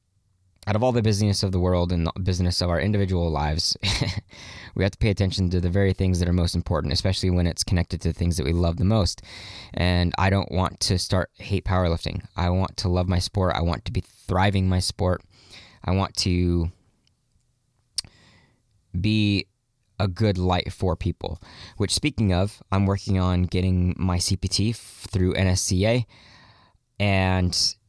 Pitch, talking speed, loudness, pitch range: 95 Hz, 180 wpm, -24 LUFS, 90-105 Hz